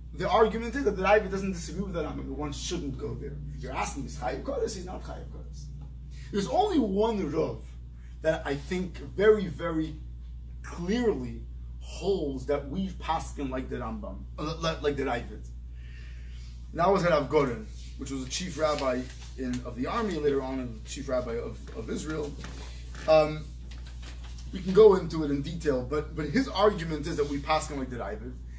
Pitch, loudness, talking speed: 140 Hz, -29 LUFS, 185 wpm